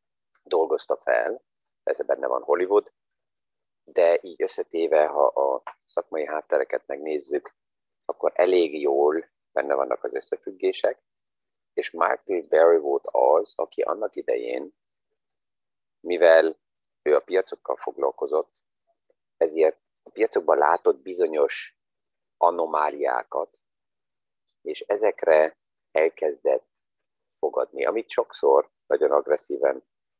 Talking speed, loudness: 95 wpm, -24 LUFS